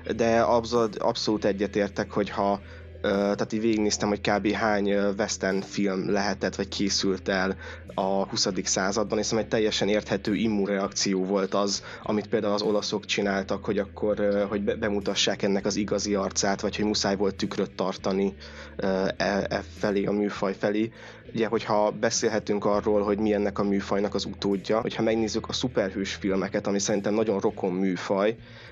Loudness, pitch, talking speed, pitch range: -26 LUFS, 100 Hz, 155 wpm, 100-105 Hz